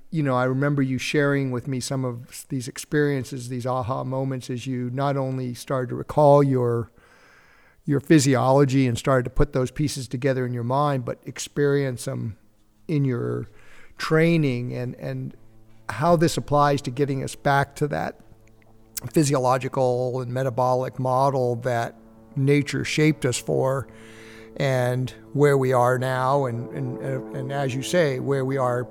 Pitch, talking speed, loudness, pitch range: 130 Hz, 155 wpm, -23 LUFS, 125-140 Hz